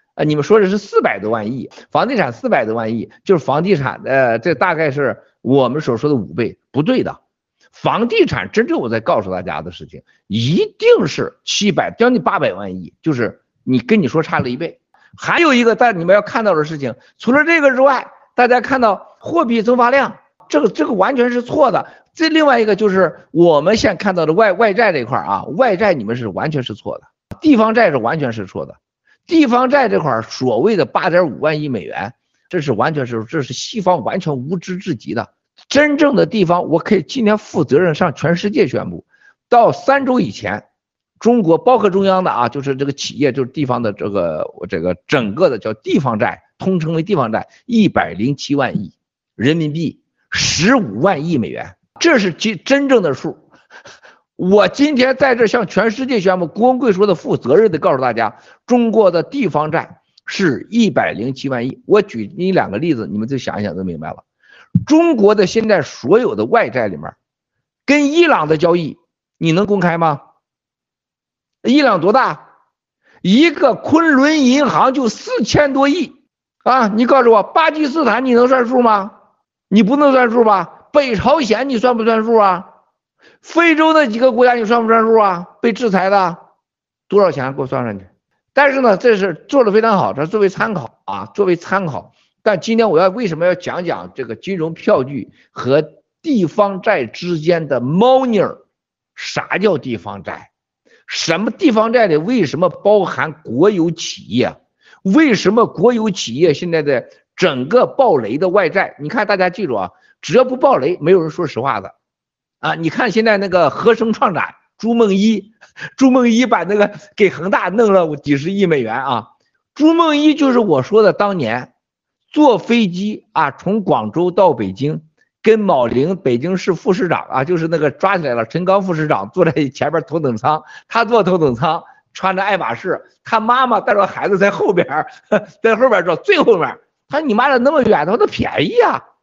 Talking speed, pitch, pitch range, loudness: 275 characters per minute, 205 Hz, 165-245 Hz, -15 LUFS